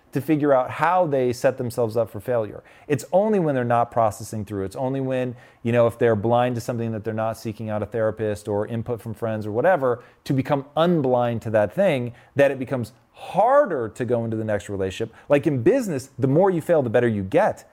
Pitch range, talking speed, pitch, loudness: 110-135 Hz, 225 wpm, 120 Hz, -22 LUFS